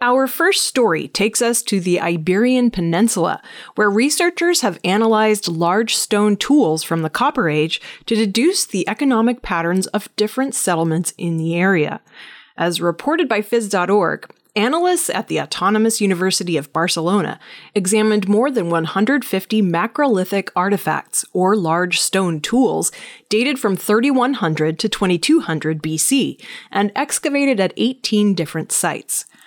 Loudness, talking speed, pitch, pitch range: -17 LUFS, 130 wpm, 210 Hz, 175-240 Hz